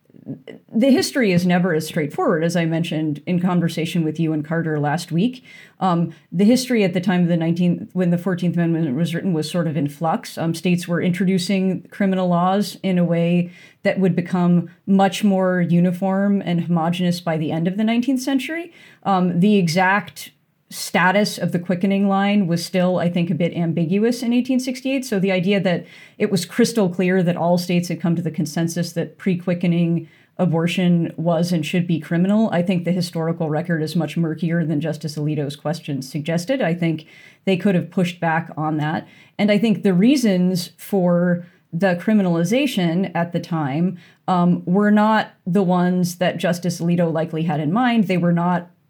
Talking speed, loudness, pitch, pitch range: 185 wpm, -20 LUFS, 175 Hz, 165-195 Hz